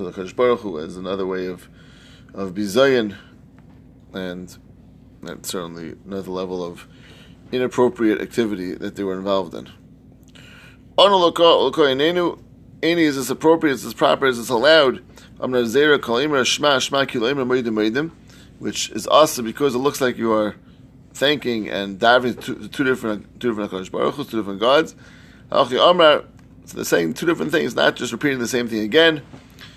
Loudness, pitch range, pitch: -19 LUFS, 95-130 Hz, 115 Hz